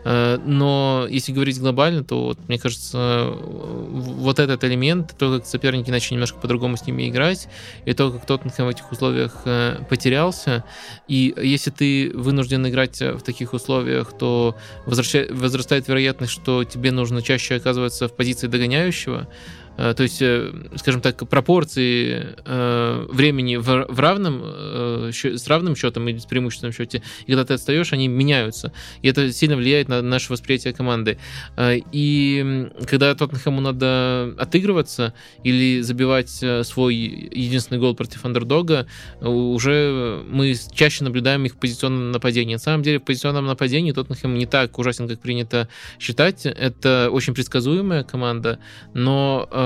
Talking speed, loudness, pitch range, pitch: 145 wpm, -20 LUFS, 120-135 Hz, 130 Hz